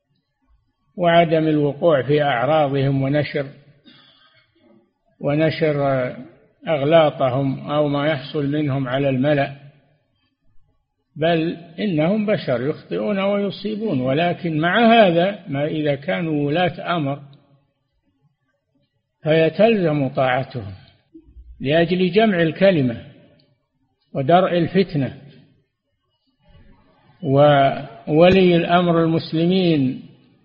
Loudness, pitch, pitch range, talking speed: -19 LUFS, 145 Hz, 135-170 Hz, 70 wpm